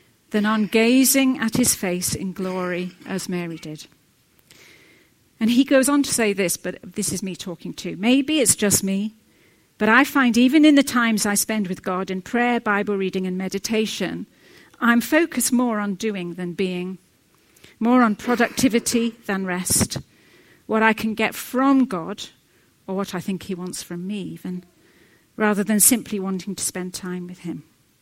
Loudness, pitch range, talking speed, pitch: -21 LUFS, 185-235 Hz, 175 wpm, 205 Hz